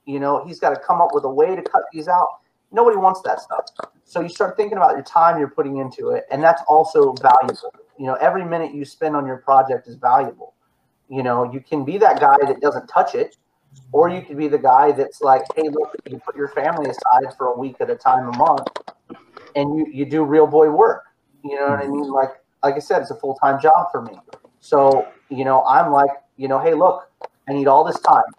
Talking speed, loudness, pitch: 240 wpm, -18 LUFS, 150 Hz